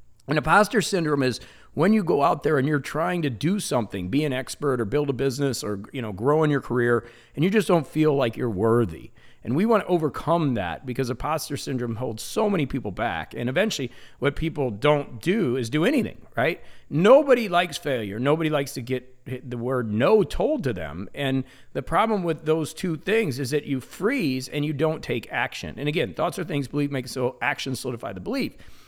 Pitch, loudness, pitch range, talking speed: 140 Hz, -24 LUFS, 125-155 Hz, 210 wpm